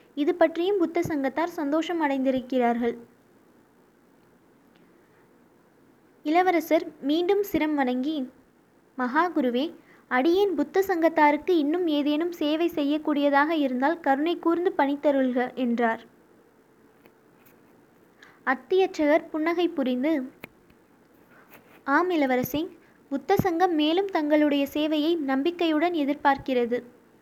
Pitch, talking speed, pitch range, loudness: 300 Hz, 80 wpm, 275-335 Hz, -25 LUFS